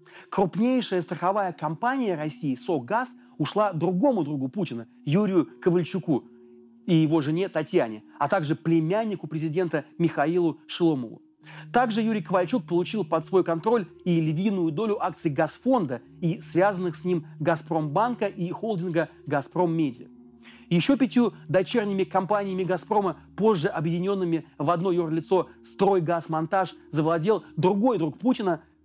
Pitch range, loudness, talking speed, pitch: 160-195 Hz, -26 LUFS, 120 wpm, 175 Hz